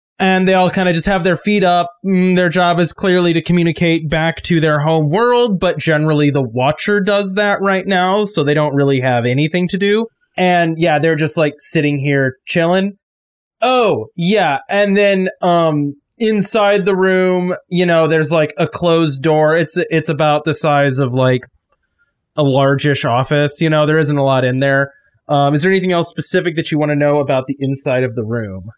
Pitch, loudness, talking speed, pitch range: 165 Hz, -14 LUFS, 200 wpm, 145-185 Hz